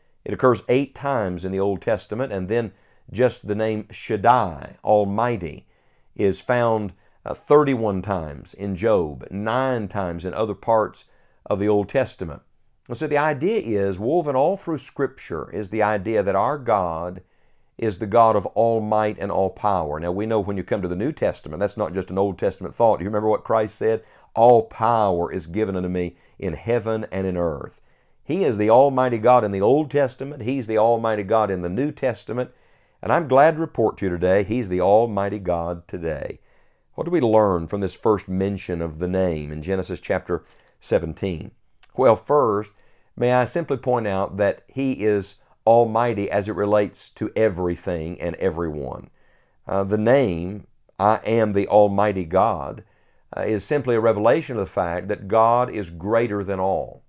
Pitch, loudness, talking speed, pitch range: 105 Hz, -22 LUFS, 180 wpm, 95-120 Hz